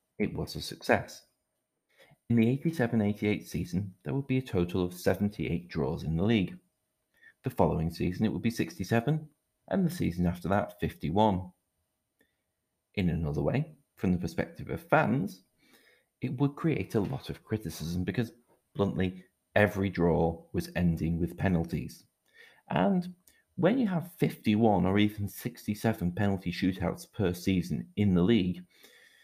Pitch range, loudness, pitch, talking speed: 85-115 Hz, -30 LUFS, 95 Hz, 145 wpm